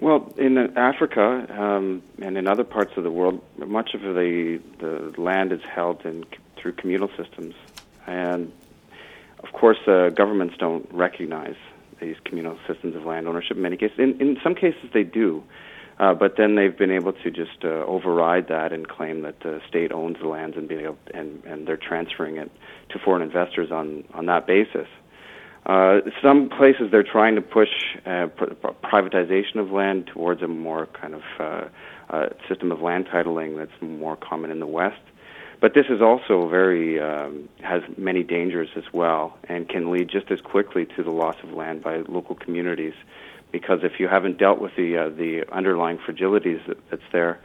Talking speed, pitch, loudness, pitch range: 185 wpm, 90 Hz, -22 LUFS, 80-100 Hz